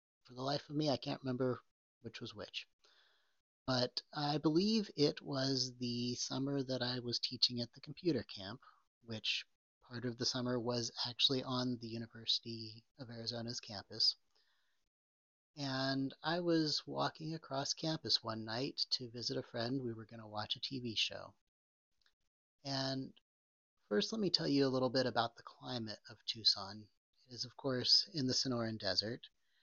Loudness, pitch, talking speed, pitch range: -37 LUFS, 125 Hz, 165 wpm, 115-135 Hz